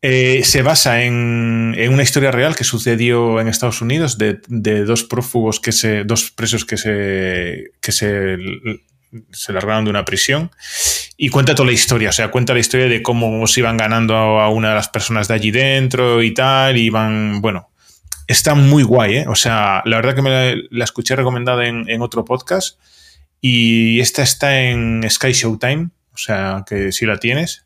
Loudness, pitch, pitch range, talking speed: -14 LUFS, 115 Hz, 110-130 Hz, 195 wpm